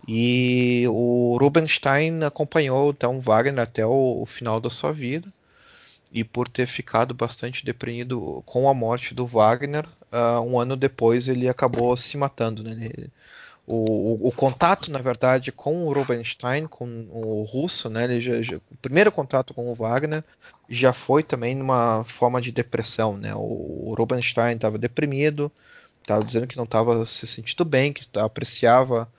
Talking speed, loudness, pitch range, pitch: 170 wpm, -23 LUFS, 115-135 Hz, 125 Hz